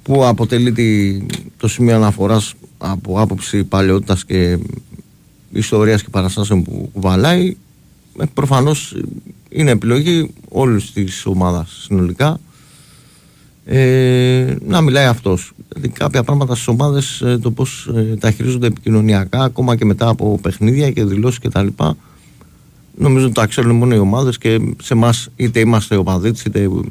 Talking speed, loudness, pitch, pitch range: 135 wpm, -15 LUFS, 115 Hz, 100-130 Hz